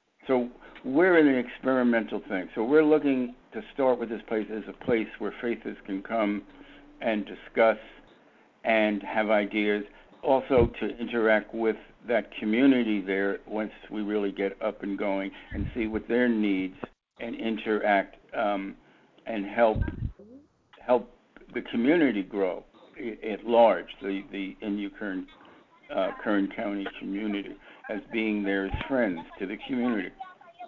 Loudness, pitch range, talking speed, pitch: -28 LUFS, 100-125 Hz, 140 wpm, 110 Hz